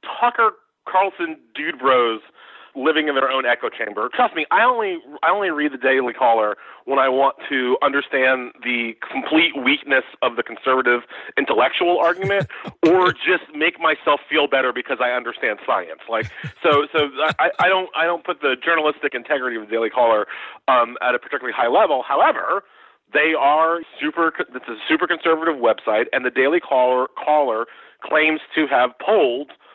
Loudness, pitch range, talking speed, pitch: -19 LUFS, 130-175 Hz, 165 wpm, 155 Hz